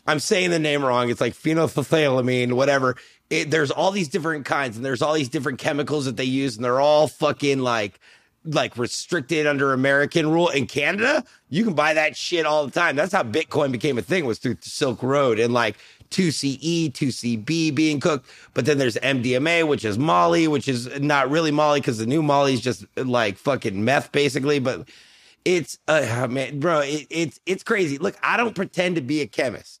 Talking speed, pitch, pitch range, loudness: 200 wpm, 145 Hz, 130-160 Hz, -22 LUFS